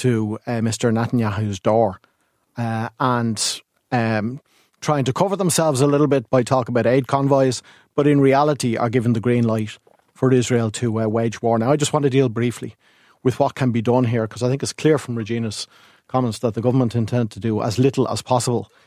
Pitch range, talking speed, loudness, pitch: 115-135 Hz, 205 wpm, -20 LUFS, 120 Hz